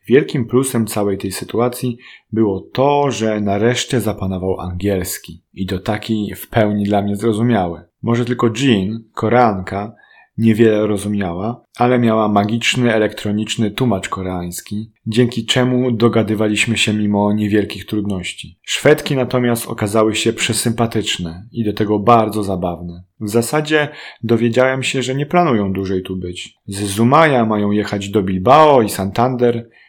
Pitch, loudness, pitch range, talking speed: 110 Hz, -16 LUFS, 100-120 Hz, 135 wpm